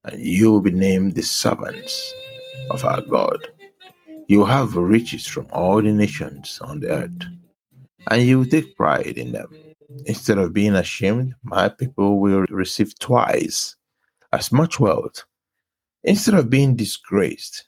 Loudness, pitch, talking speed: -19 LUFS, 130 Hz, 145 wpm